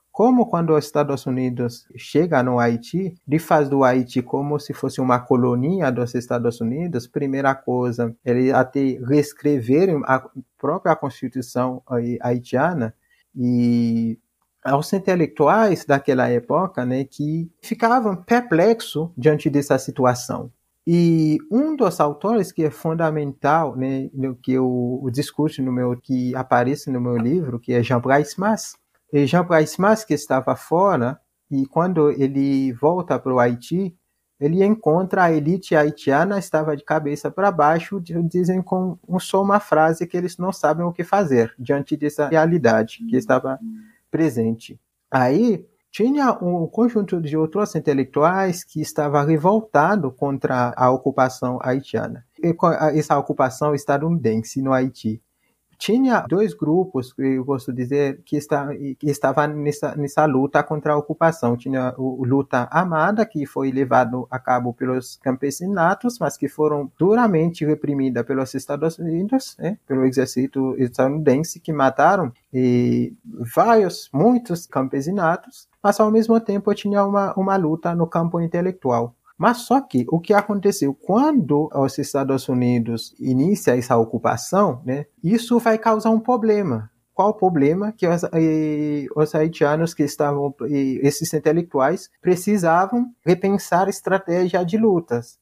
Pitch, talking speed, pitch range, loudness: 150 Hz, 135 wpm, 130-180 Hz, -20 LUFS